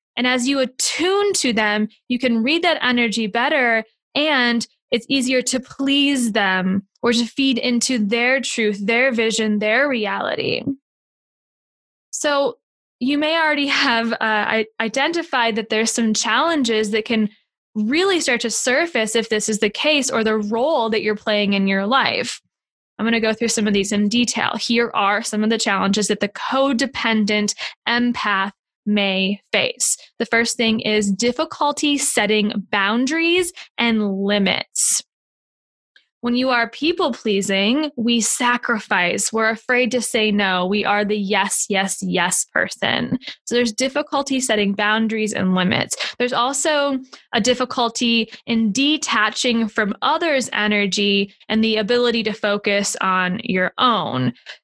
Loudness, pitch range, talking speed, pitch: -19 LUFS, 210-260 Hz, 145 wpm, 230 Hz